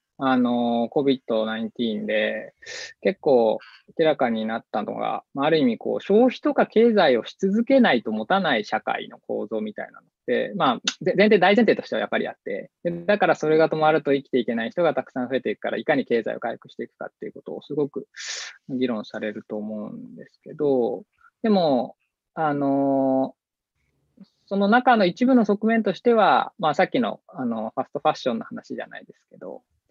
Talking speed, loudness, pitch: 355 characters per minute, -22 LUFS, 155 Hz